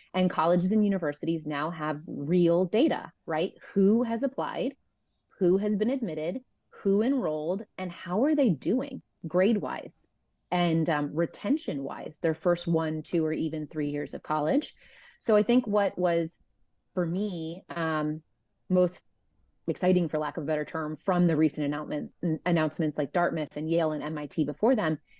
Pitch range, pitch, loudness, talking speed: 155-200 Hz, 170 Hz, -28 LUFS, 155 wpm